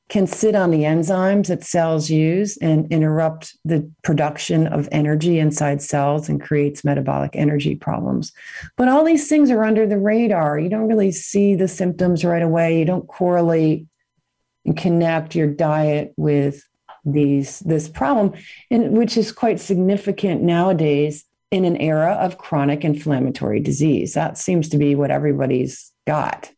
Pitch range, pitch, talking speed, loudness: 150-190 Hz, 165 Hz, 155 wpm, -19 LUFS